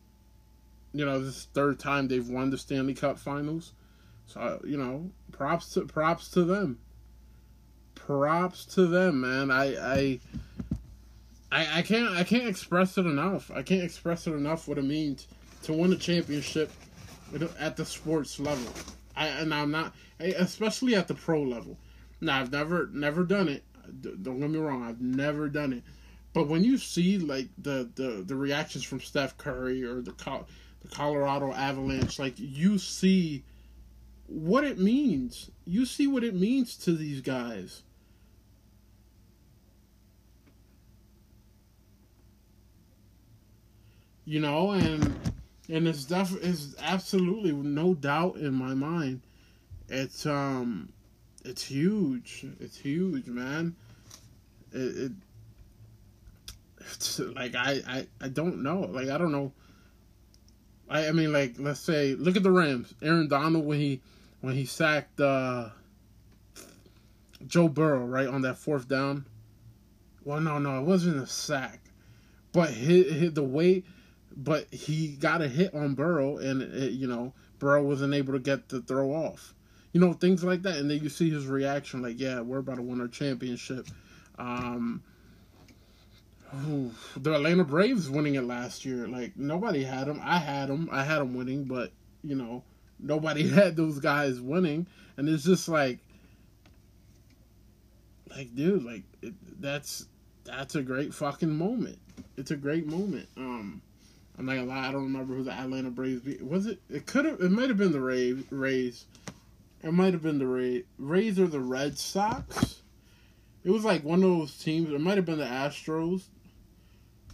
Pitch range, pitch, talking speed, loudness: 115-160 Hz, 135 Hz, 155 wpm, -29 LUFS